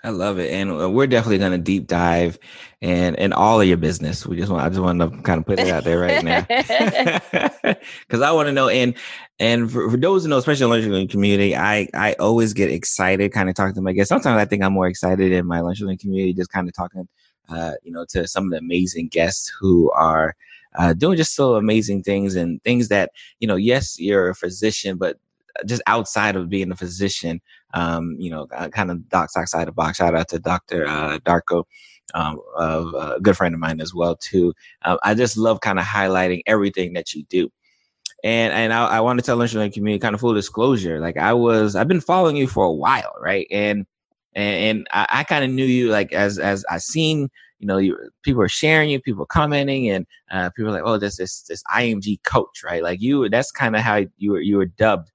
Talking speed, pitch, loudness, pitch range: 230 wpm, 95 Hz, -19 LUFS, 90-110 Hz